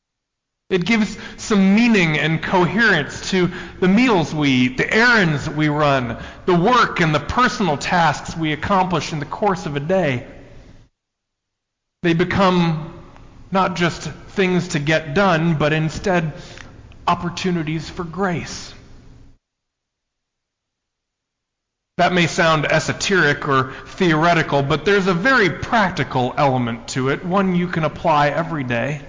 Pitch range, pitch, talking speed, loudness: 145-185 Hz, 165 Hz, 130 wpm, -18 LUFS